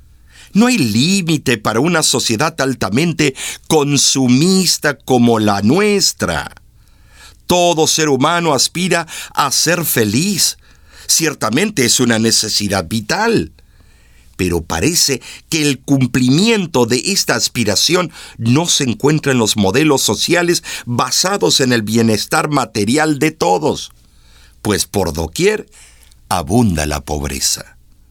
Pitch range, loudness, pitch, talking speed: 105-155 Hz, -14 LUFS, 130 Hz, 110 wpm